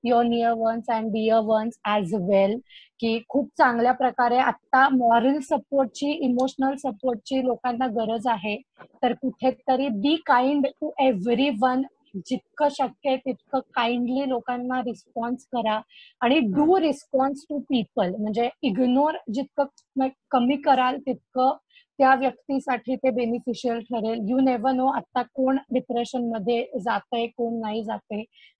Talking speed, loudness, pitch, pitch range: 130 wpm, -24 LUFS, 255 Hz, 235-270 Hz